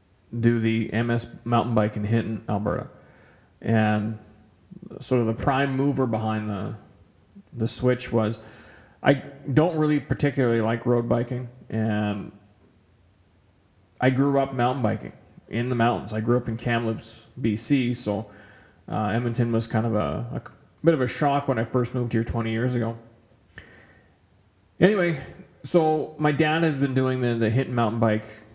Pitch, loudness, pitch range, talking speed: 115 Hz, -24 LUFS, 105-130 Hz, 155 wpm